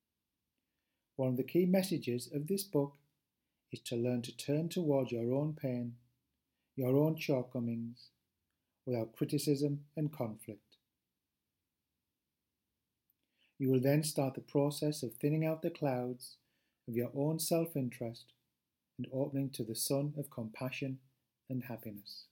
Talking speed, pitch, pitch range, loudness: 130 wpm, 130 Hz, 120-145 Hz, -36 LUFS